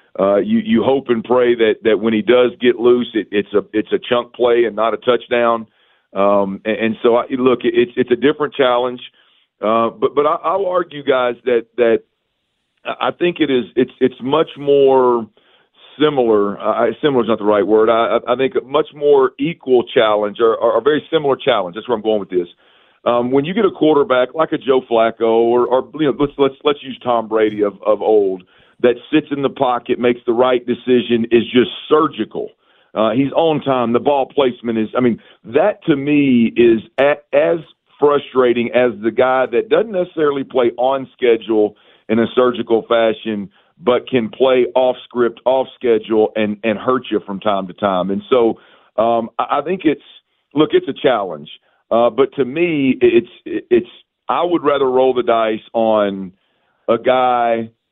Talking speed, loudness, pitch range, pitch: 190 wpm, -16 LUFS, 115-140 Hz, 125 Hz